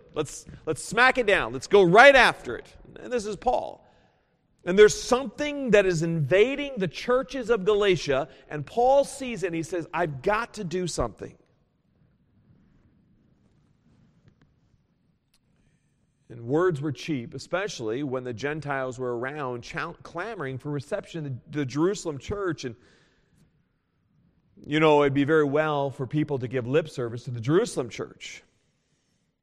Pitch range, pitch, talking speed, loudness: 140-205 Hz, 160 Hz, 145 wpm, -25 LUFS